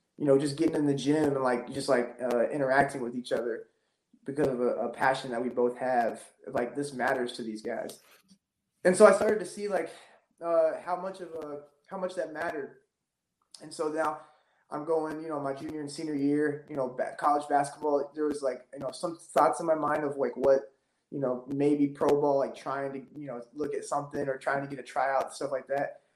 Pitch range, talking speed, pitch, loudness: 135-160 Hz, 225 wpm, 145 Hz, -29 LUFS